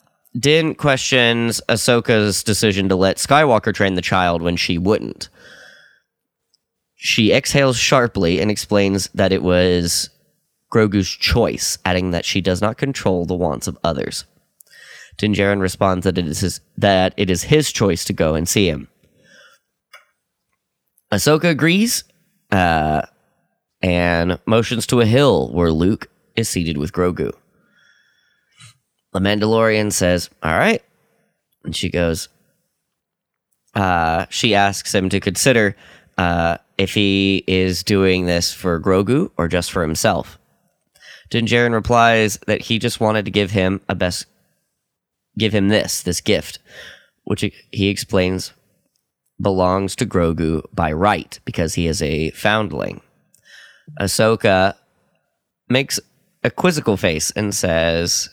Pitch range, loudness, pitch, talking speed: 90-110 Hz, -17 LUFS, 95 Hz, 130 wpm